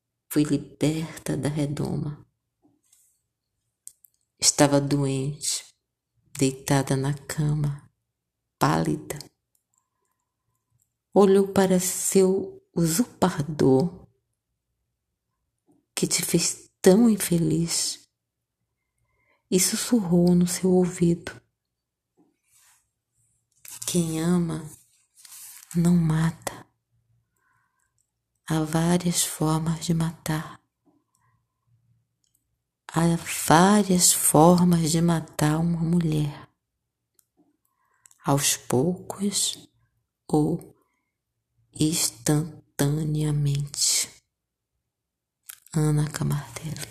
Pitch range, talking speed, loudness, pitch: 135-175 Hz, 60 wpm, -23 LUFS, 155 Hz